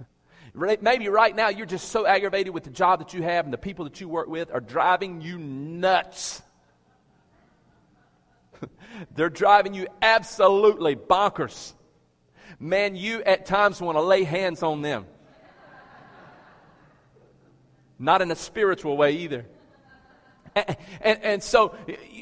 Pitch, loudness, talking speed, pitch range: 185 Hz, -23 LUFS, 130 wpm, 160-200 Hz